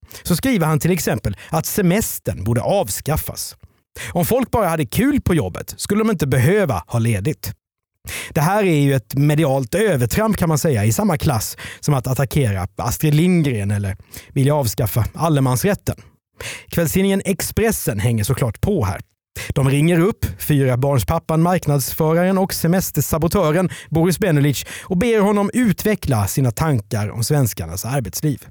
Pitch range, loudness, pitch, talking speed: 120-175 Hz, -18 LUFS, 145 Hz, 145 wpm